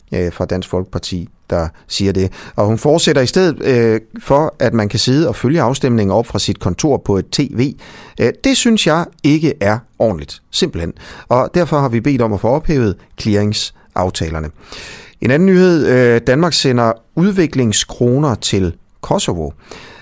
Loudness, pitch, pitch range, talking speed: -15 LUFS, 115 Hz, 95-145 Hz, 155 wpm